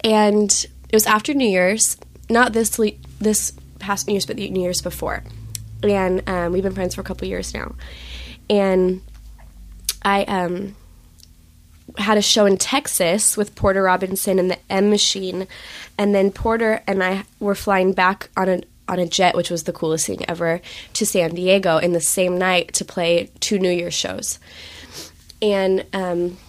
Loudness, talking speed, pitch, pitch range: -19 LUFS, 175 wpm, 185 Hz, 170-200 Hz